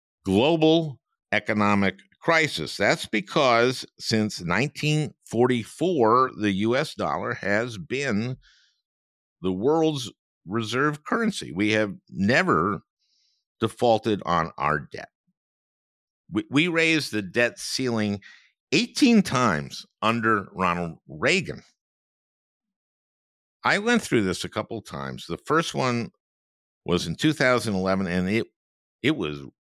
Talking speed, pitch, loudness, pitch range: 105 wpm, 110 Hz, -24 LUFS, 95-145 Hz